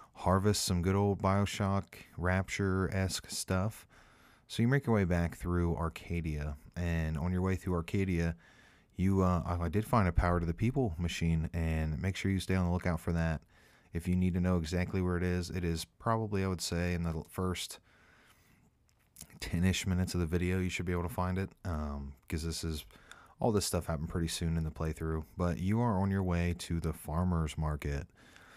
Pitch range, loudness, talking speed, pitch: 85-95 Hz, -34 LUFS, 200 wpm, 90 Hz